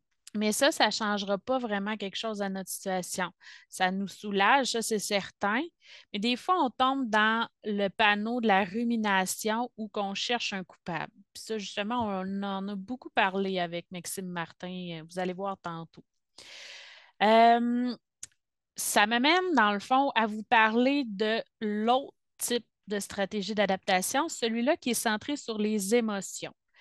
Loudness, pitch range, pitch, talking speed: -28 LUFS, 195-240 Hz, 215 Hz, 160 wpm